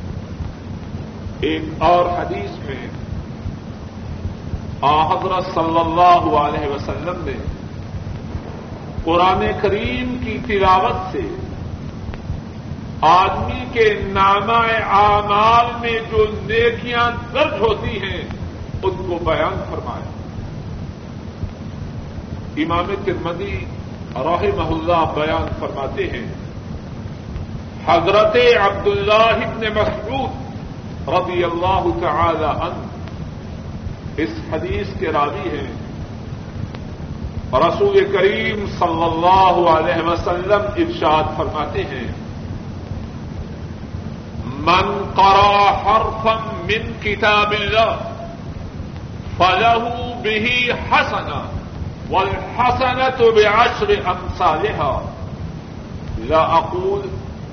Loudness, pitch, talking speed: -17 LUFS, 180 Hz, 75 wpm